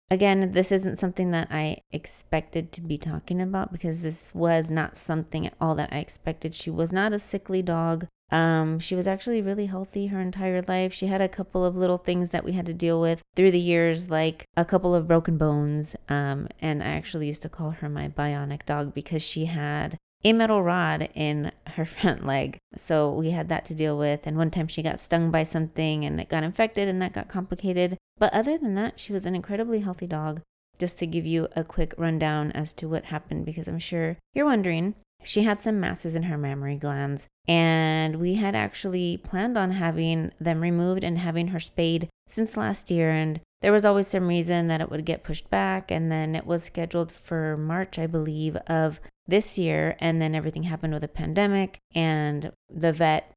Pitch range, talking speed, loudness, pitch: 155-185 Hz, 210 wpm, -26 LUFS, 165 Hz